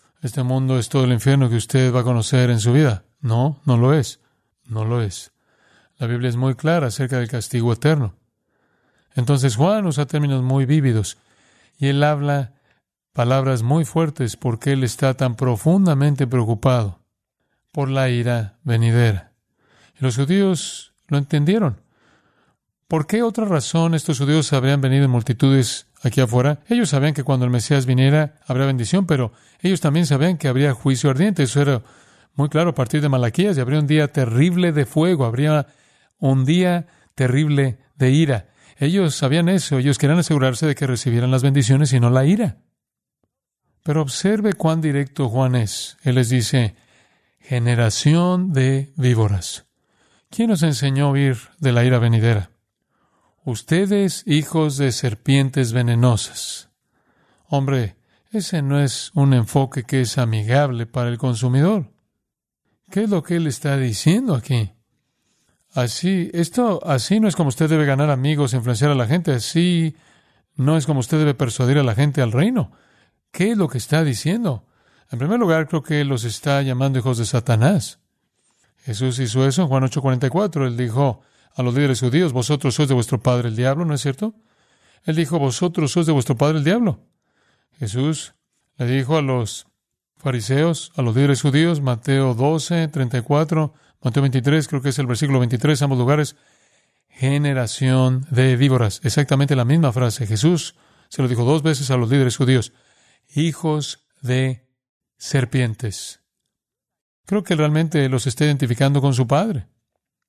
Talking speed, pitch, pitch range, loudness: 160 wpm, 140 Hz, 125-155 Hz, -19 LUFS